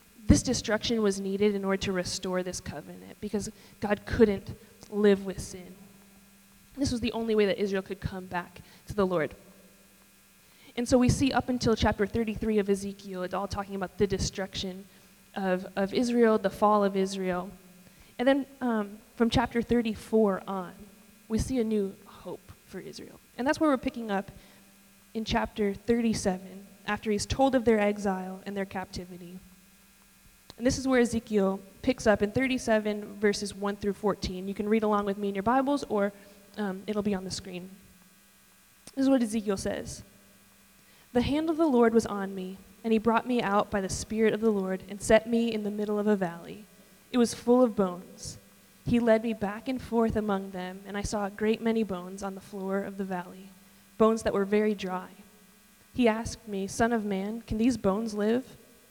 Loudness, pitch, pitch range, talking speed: -29 LUFS, 205 Hz, 195-225 Hz, 190 wpm